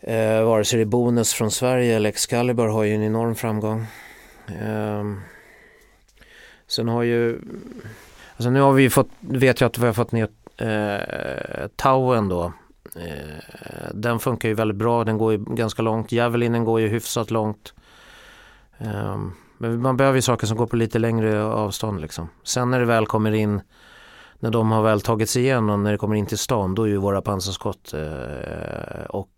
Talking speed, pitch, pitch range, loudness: 185 wpm, 110 Hz, 105-120 Hz, -22 LUFS